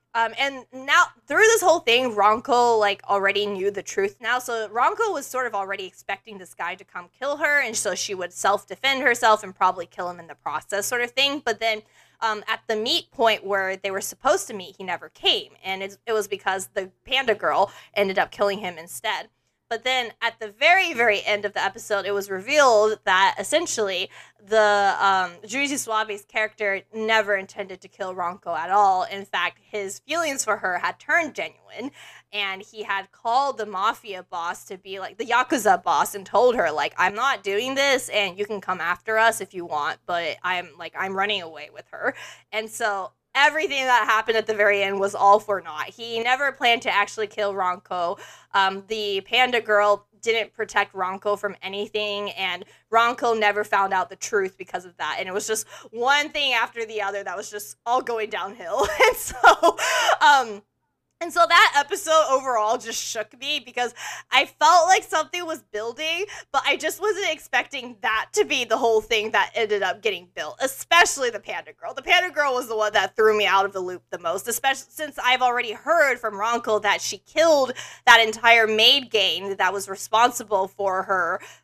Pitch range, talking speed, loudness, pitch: 195-255 Hz, 200 wpm, -22 LUFS, 215 Hz